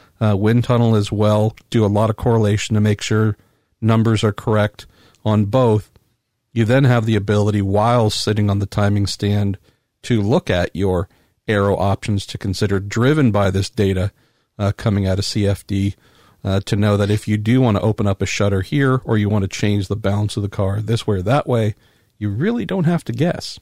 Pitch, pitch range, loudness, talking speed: 105 Hz, 100-115 Hz, -18 LUFS, 205 wpm